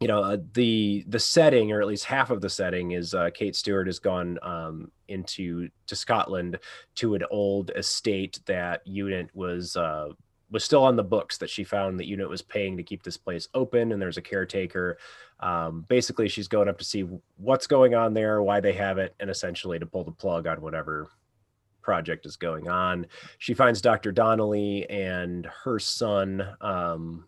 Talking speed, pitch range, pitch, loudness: 190 wpm, 90-105 Hz, 95 Hz, -26 LUFS